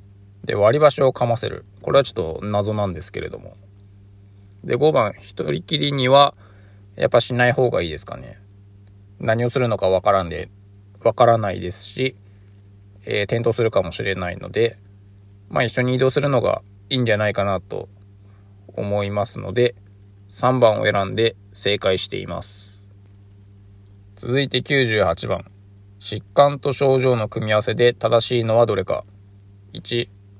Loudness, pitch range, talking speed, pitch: -20 LUFS, 100-120 Hz, 280 characters per minute, 100 Hz